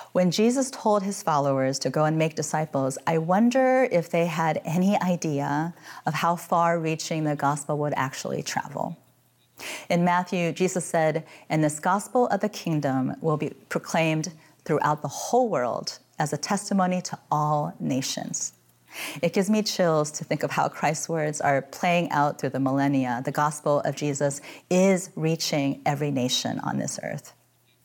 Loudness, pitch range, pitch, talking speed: -25 LUFS, 145-180 Hz, 160 Hz, 165 wpm